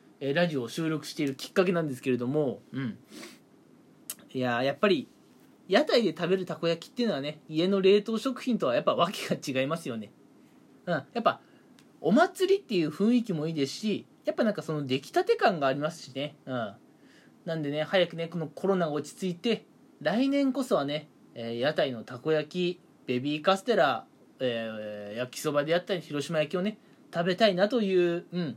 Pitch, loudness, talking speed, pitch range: 165 Hz, -29 LUFS, 370 characters per minute, 145-195 Hz